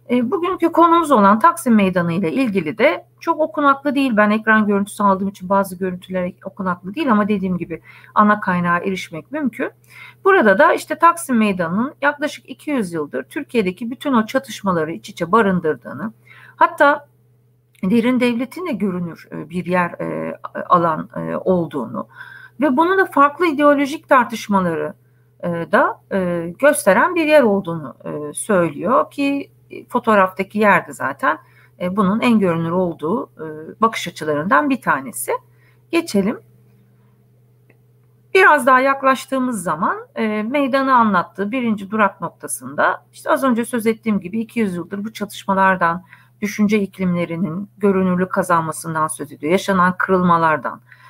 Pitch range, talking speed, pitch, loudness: 175-265 Hz, 120 wpm, 200 Hz, -18 LUFS